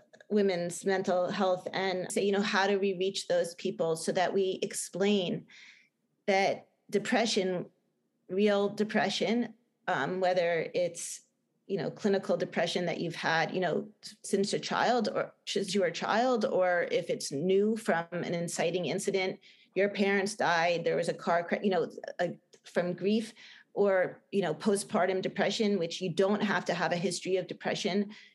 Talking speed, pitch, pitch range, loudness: 165 wpm, 195 Hz, 180-210 Hz, -30 LUFS